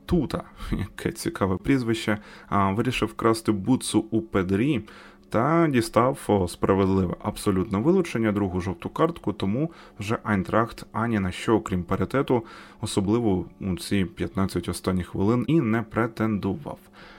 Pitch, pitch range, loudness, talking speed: 105 Hz, 95-115 Hz, -25 LUFS, 120 wpm